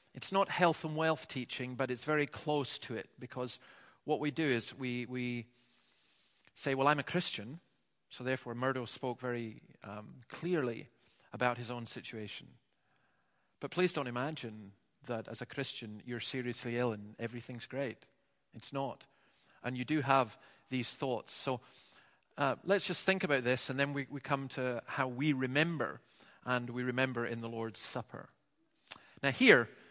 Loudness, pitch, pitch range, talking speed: -35 LUFS, 130 Hz, 120-140 Hz, 165 wpm